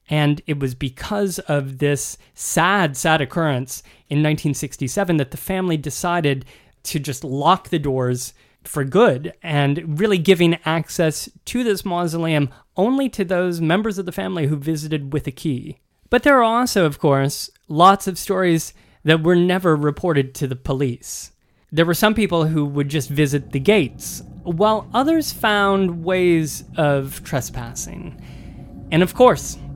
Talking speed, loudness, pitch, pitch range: 155 wpm, -19 LUFS, 160 Hz, 145-185 Hz